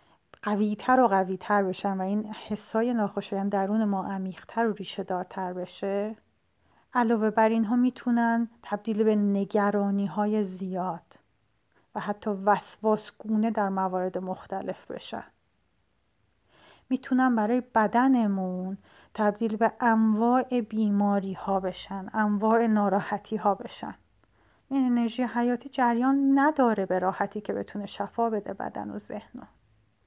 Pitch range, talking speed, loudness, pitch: 195-230 Hz, 125 wpm, -27 LUFS, 210 Hz